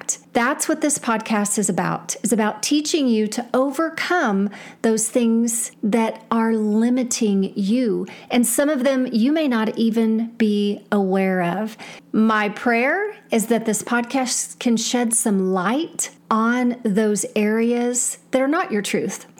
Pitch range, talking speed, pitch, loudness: 215-250 Hz, 145 wpm, 230 Hz, -20 LUFS